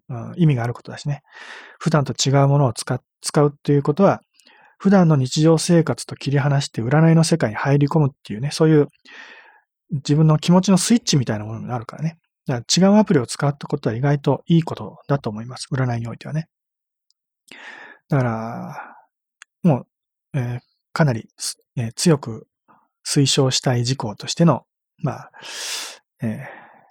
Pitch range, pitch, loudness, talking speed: 130-165 Hz, 145 Hz, -20 LUFS, 335 characters per minute